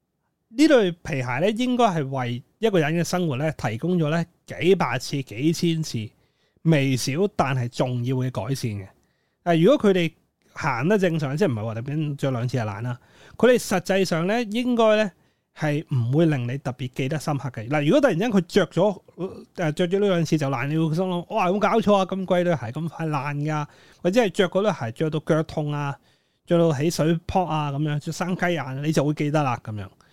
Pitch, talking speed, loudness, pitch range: 160 Hz, 295 characters per minute, -23 LUFS, 135-180 Hz